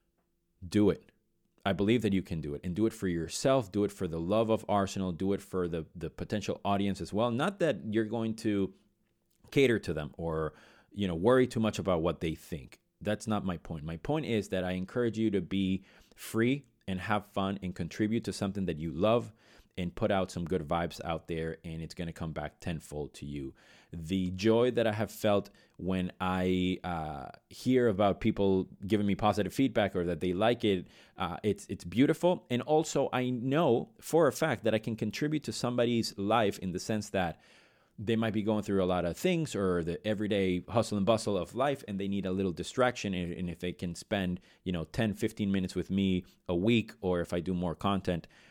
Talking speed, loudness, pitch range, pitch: 215 wpm, -32 LUFS, 90-110 Hz, 100 Hz